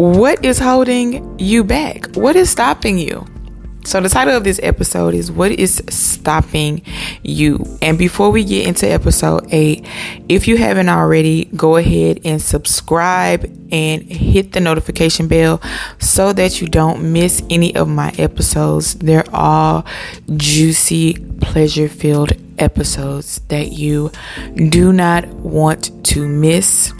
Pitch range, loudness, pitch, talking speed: 145-185 Hz, -13 LUFS, 160 Hz, 140 wpm